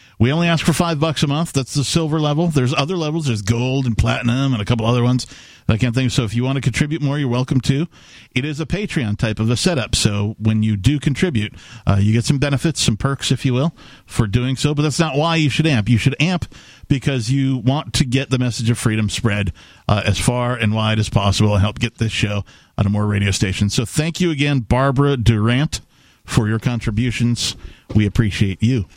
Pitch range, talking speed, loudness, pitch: 110-145 Hz, 230 wpm, -18 LUFS, 125 Hz